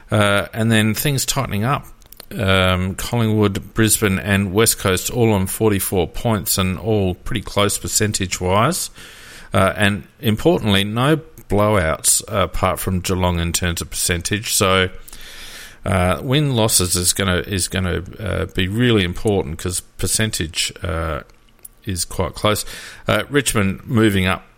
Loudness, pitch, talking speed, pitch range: -18 LUFS, 100 Hz, 140 wpm, 95-110 Hz